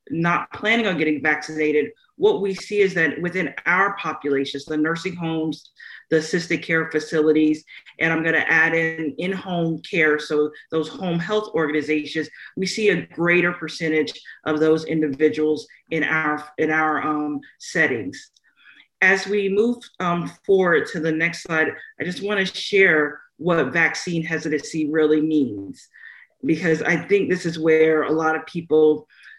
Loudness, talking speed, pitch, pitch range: -21 LUFS, 155 wpm, 160 Hz, 155-175 Hz